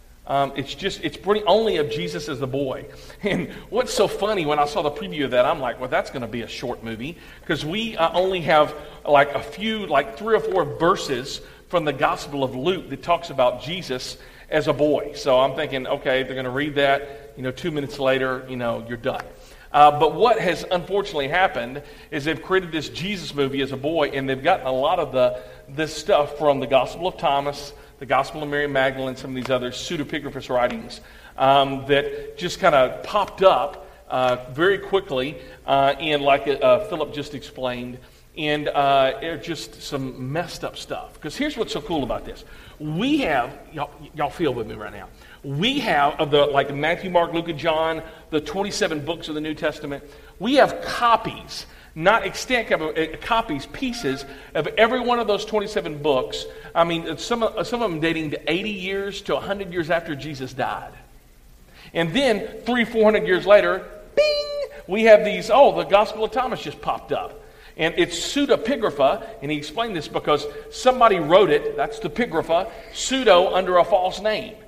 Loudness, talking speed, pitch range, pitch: -22 LUFS, 195 wpm, 140-195 Hz, 155 Hz